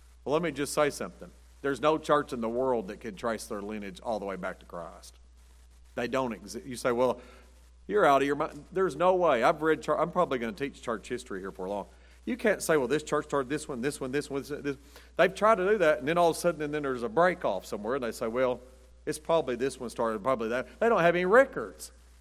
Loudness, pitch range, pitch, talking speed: -29 LUFS, 110-155 Hz, 135 Hz, 265 wpm